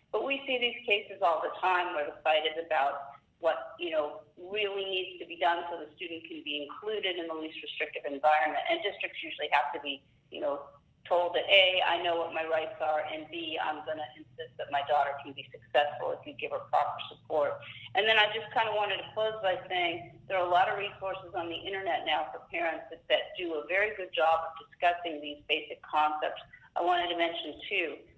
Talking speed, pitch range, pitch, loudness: 230 wpm, 155-190 Hz, 165 Hz, -31 LUFS